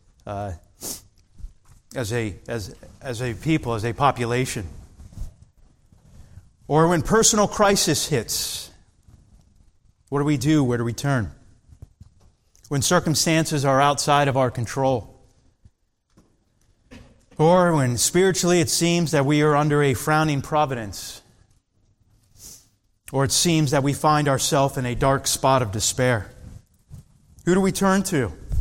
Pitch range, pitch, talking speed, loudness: 105-150 Hz, 125 Hz, 125 wpm, -21 LUFS